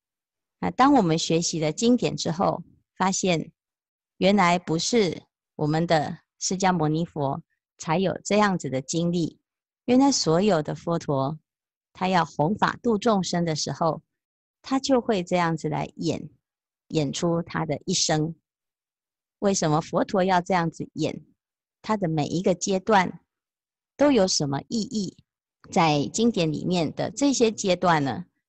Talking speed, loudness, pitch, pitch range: 205 characters per minute, -24 LUFS, 175 Hz, 160-205 Hz